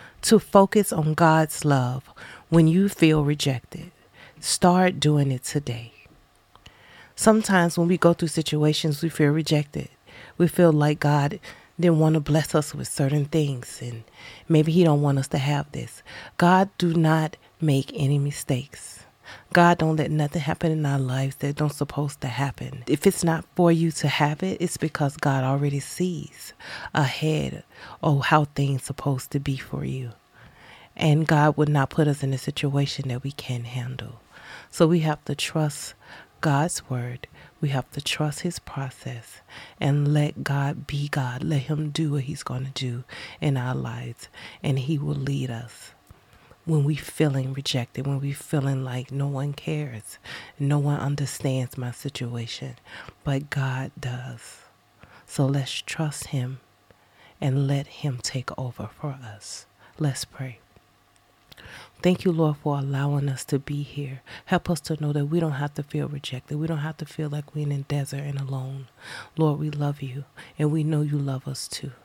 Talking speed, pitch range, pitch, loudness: 170 wpm, 135-155 Hz, 145 Hz, -24 LUFS